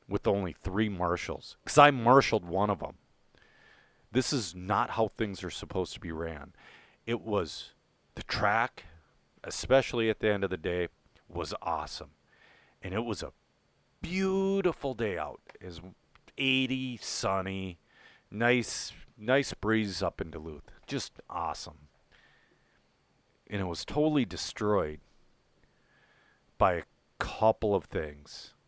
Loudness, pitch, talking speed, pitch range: -30 LUFS, 105 Hz, 130 wpm, 90-125 Hz